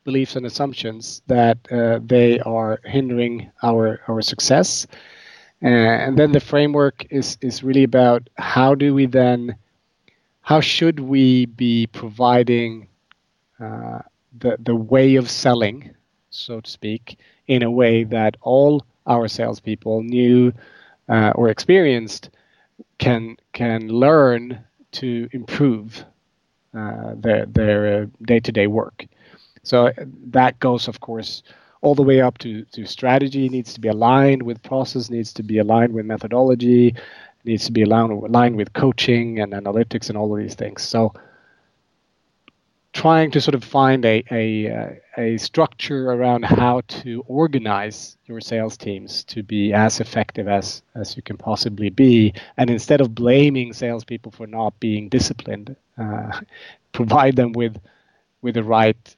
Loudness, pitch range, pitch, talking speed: -18 LUFS, 110-130 Hz, 120 Hz, 145 wpm